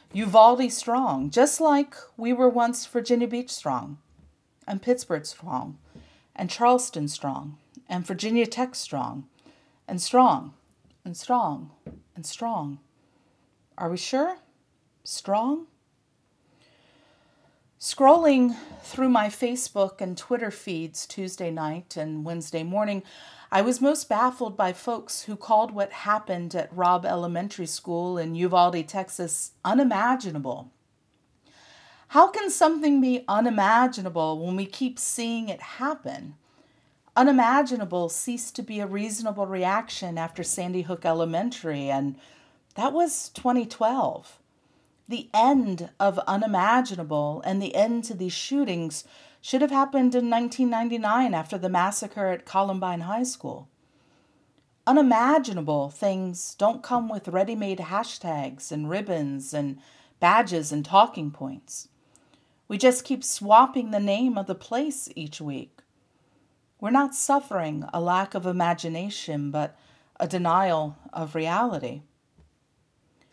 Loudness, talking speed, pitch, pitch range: -25 LUFS, 120 wpm, 200 Hz, 165-245 Hz